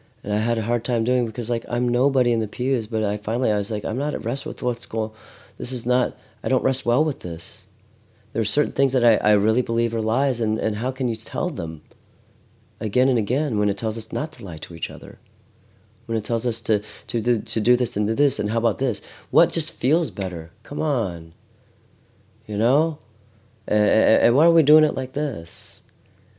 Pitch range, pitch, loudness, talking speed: 105-125 Hz, 115 Hz, -22 LUFS, 230 wpm